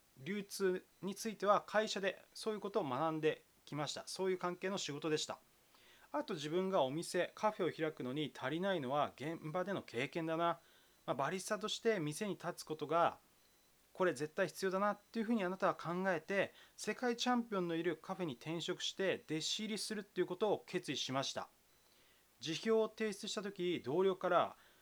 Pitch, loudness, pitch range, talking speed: 180 Hz, -39 LUFS, 160-205 Hz, 370 characters per minute